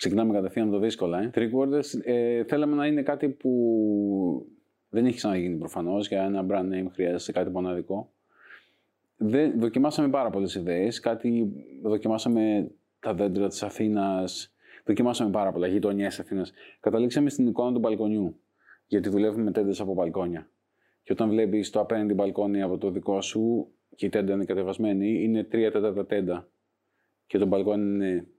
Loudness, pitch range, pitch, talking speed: -27 LUFS, 100-115 Hz, 105 Hz, 155 wpm